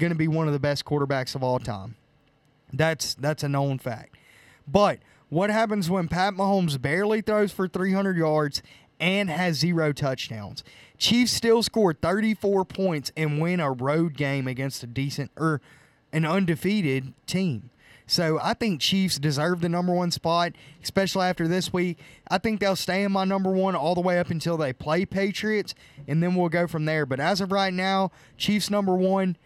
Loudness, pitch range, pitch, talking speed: -25 LUFS, 145-190 Hz, 170 Hz, 185 wpm